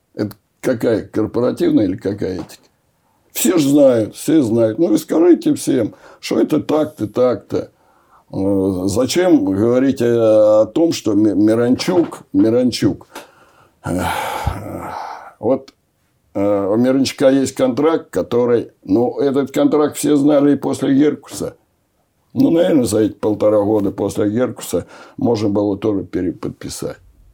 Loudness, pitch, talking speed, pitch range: -16 LUFS, 130 Hz, 110 wpm, 110-155 Hz